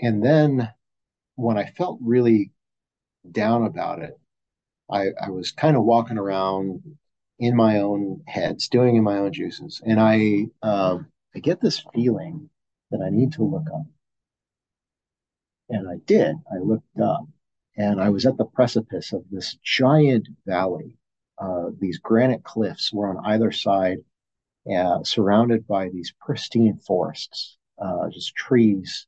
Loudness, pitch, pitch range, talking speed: -22 LUFS, 110 Hz, 100-125 Hz, 145 wpm